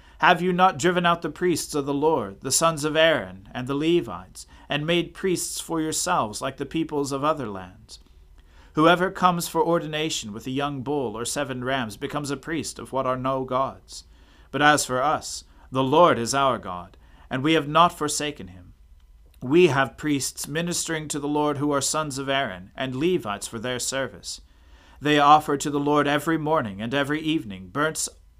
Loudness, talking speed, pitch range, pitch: -23 LUFS, 190 wpm, 110-155 Hz, 140 Hz